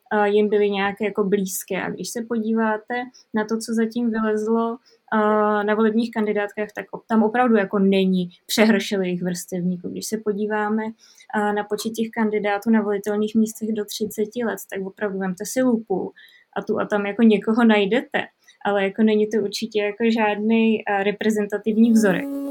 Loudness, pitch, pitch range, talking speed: -22 LUFS, 215 Hz, 205-225 Hz, 155 wpm